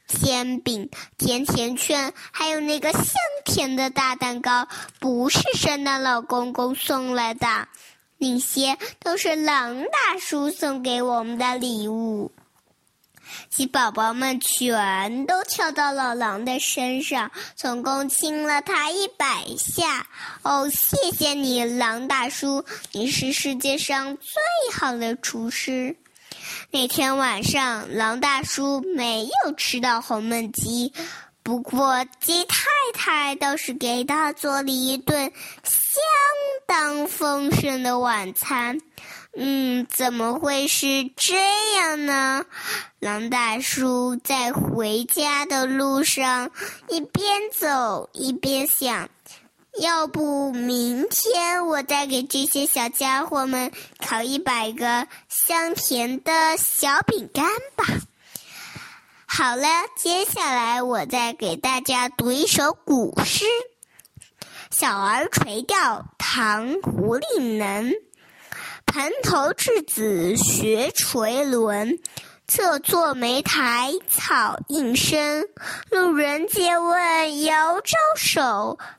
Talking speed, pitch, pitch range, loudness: 155 characters per minute, 275 Hz, 245-310 Hz, -22 LUFS